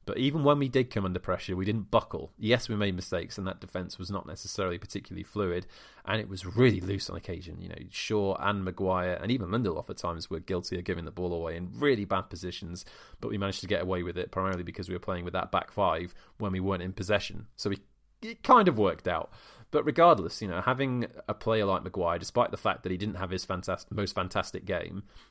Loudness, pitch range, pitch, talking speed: -30 LUFS, 90-105 Hz, 95 Hz, 240 wpm